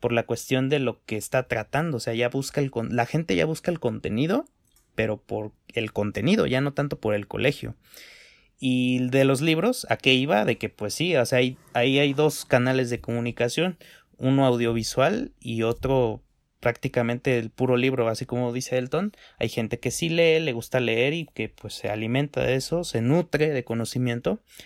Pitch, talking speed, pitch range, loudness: 125 Hz, 195 wpm, 115-140 Hz, -25 LUFS